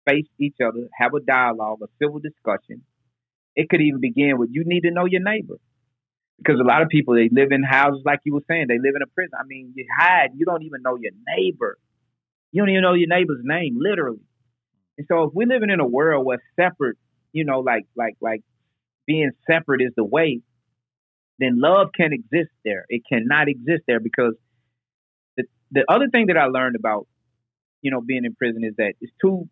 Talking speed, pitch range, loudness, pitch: 210 wpm, 120-160 Hz, -20 LUFS, 135 Hz